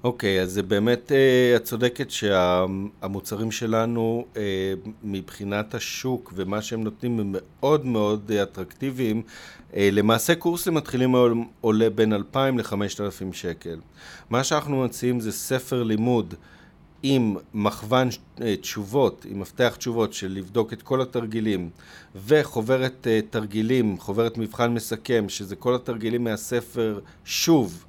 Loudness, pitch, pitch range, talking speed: -24 LUFS, 110 Hz, 100-125 Hz, 130 wpm